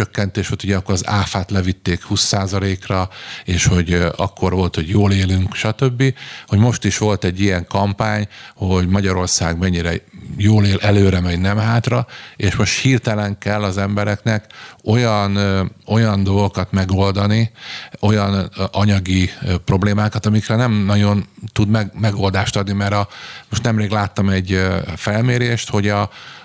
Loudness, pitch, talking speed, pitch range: -17 LUFS, 100 Hz, 135 wpm, 95-105 Hz